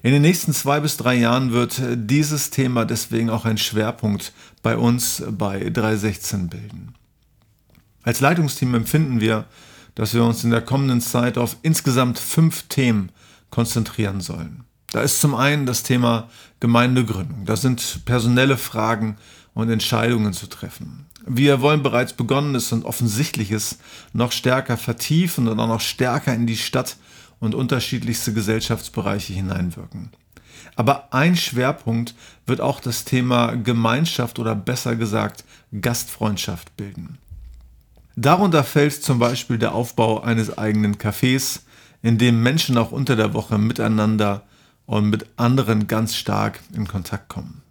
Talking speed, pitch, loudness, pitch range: 135 wpm, 120 Hz, -20 LUFS, 110-130 Hz